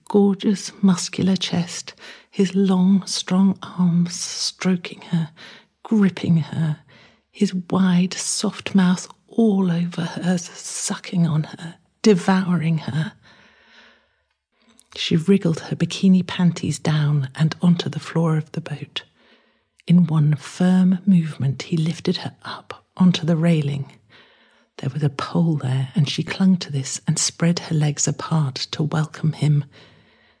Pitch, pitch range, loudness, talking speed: 170 Hz, 155-185 Hz, -21 LUFS, 130 wpm